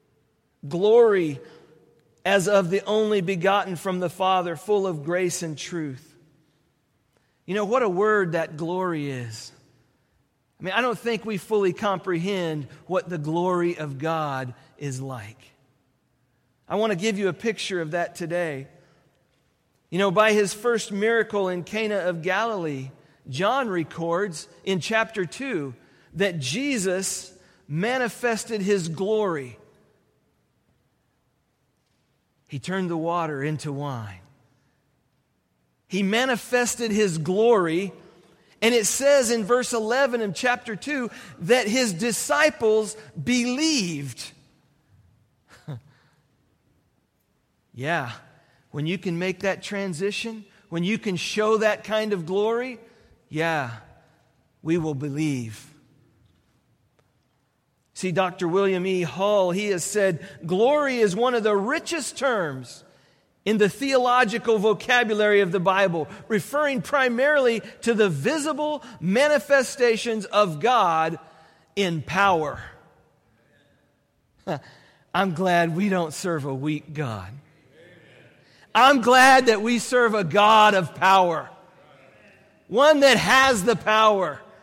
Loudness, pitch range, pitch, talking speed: -23 LUFS, 155-220 Hz, 185 Hz, 115 wpm